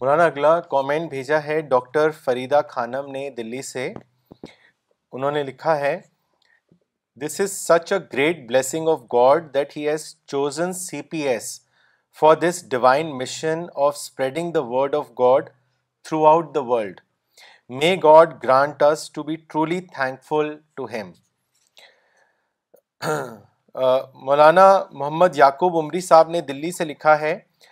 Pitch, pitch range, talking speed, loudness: 150 Hz, 135-160 Hz, 140 wpm, -20 LUFS